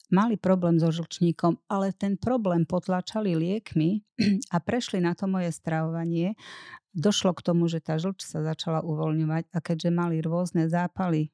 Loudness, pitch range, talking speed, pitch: -27 LUFS, 165-195 Hz, 155 wpm, 175 Hz